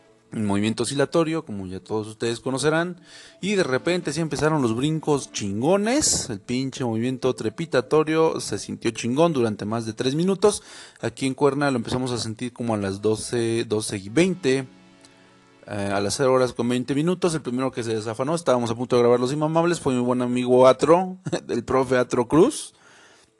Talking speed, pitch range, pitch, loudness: 180 wpm, 115-155 Hz, 125 Hz, -23 LUFS